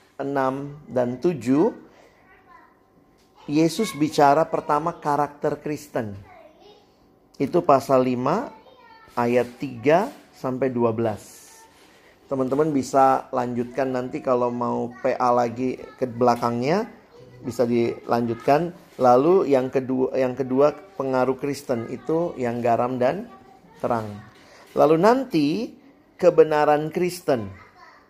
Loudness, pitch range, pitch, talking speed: -22 LUFS, 125-150 Hz, 135 Hz, 90 wpm